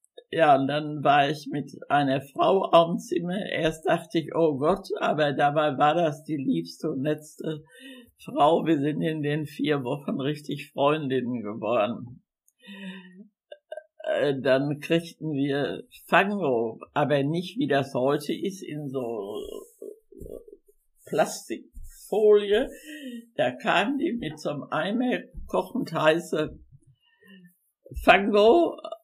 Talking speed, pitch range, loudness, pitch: 115 wpm, 145-215 Hz, -25 LUFS, 160 Hz